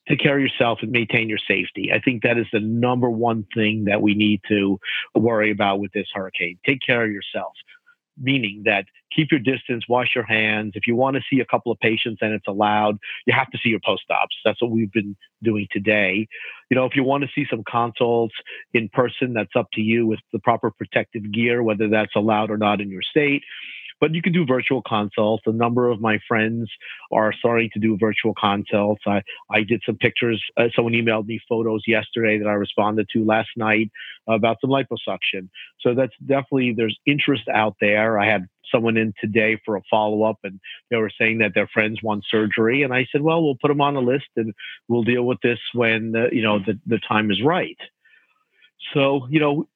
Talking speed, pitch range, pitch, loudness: 215 wpm, 105-125 Hz, 115 Hz, -21 LUFS